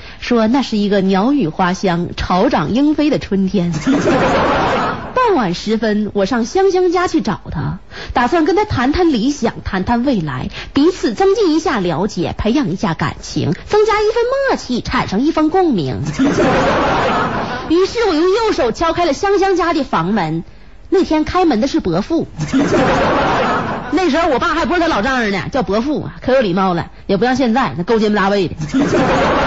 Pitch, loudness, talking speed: 270 Hz, -15 LUFS, 245 characters per minute